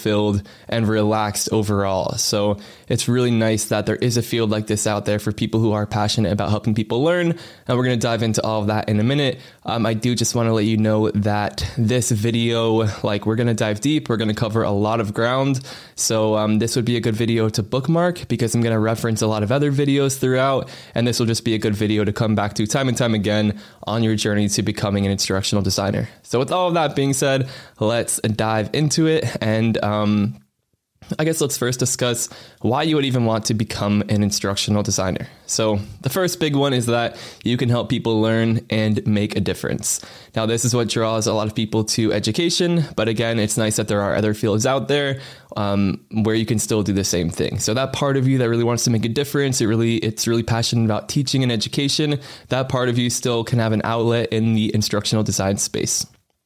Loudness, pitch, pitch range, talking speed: -20 LUFS, 115 Hz, 105-125 Hz, 235 wpm